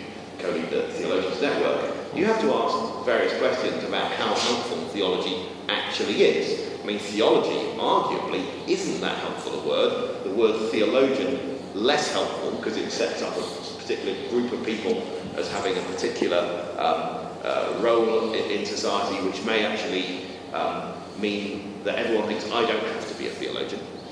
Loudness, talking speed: -25 LUFS, 160 wpm